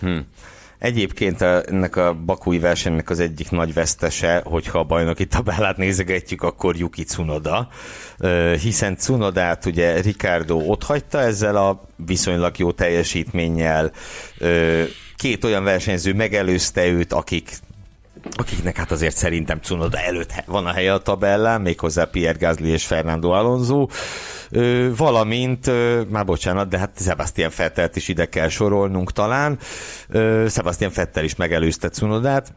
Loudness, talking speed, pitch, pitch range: -20 LUFS, 135 wpm, 90 Hz, 85-105 Hz